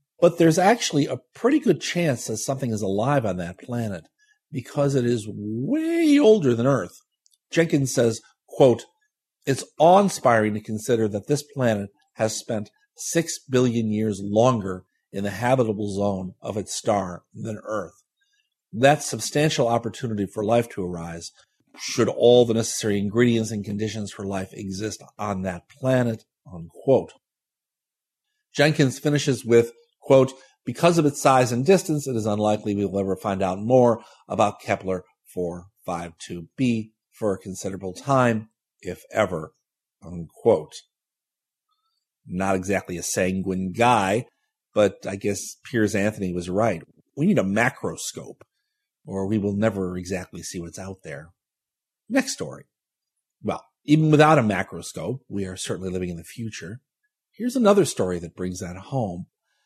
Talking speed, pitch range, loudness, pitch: 145 wpm, 95-140 Hz, -23 LUFS, 110 Hz